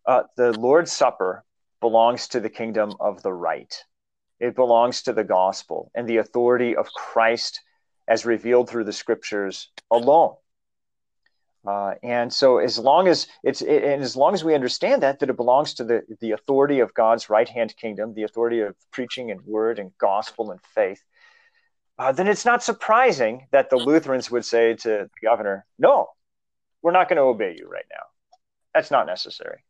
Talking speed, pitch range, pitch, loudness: 180 wpm, 110-155 Hz, 120 Hz, -21 LUFS